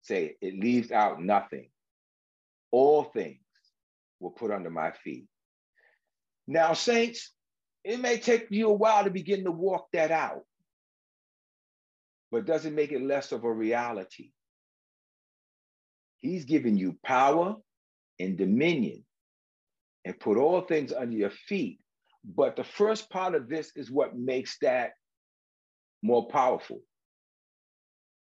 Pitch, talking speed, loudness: 155 Hz, 125 wpm, -28 LUFS